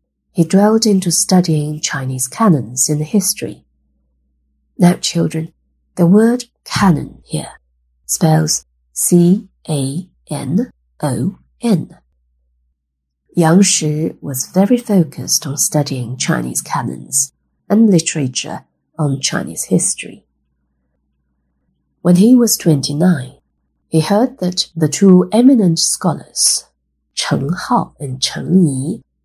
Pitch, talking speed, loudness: 150 Hz, 95 wpm, -15 LUFS